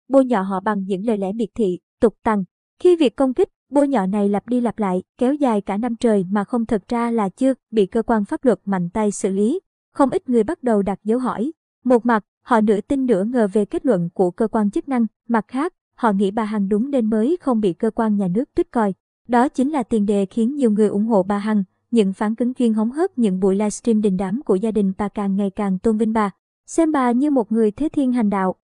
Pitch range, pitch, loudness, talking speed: 205-250 Hz, 225 Hz, -20 LUFS, 260 wpm